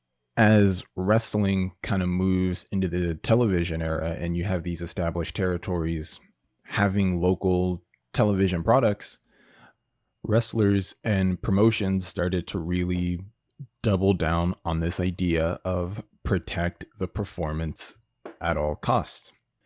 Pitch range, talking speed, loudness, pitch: 85-100 Hz, 115 wpm, -26 LUFS, 90 Hz